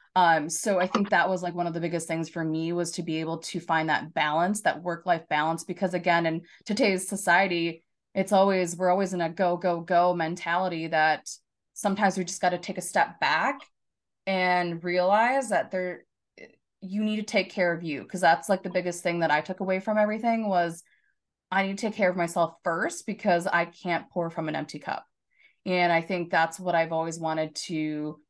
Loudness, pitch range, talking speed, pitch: -26 LUFS, 165-190 Hz, 210 wpm, 175 Hz